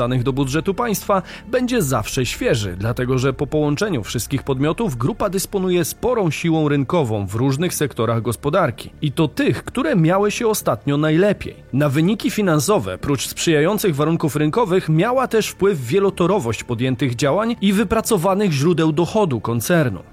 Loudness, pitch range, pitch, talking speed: -19 LUFS, 135-195 Hz, 160 Hz, 140 wpm